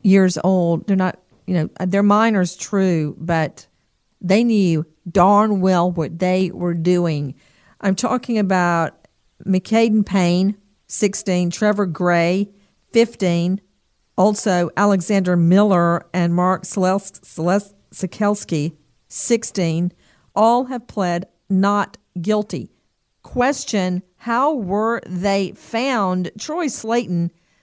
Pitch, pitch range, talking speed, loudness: 190 Hz, 175-205 Hz, 105 wpm, -19 LUFS